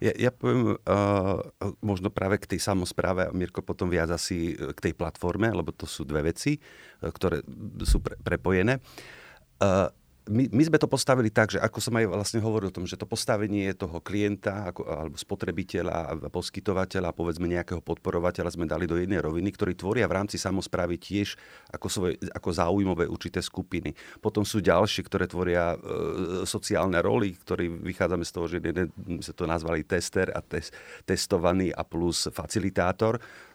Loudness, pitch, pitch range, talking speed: -28 LUFS, 95 Hz, 85-105 Hz, 165 wpm